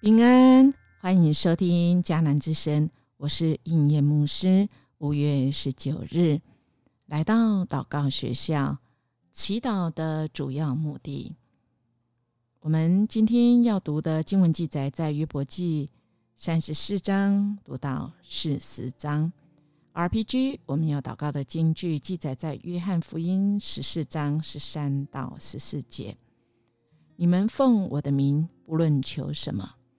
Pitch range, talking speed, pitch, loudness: 140-175 Hz, 190 characters per minute, 155 Hz, -25 LUFS